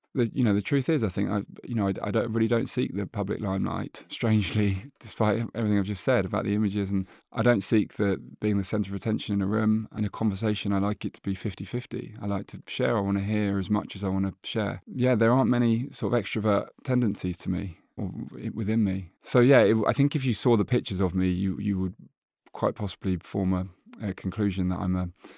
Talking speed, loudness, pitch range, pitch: 245 wpm, -27 LUFS, 95-115 Hz, 105 Hz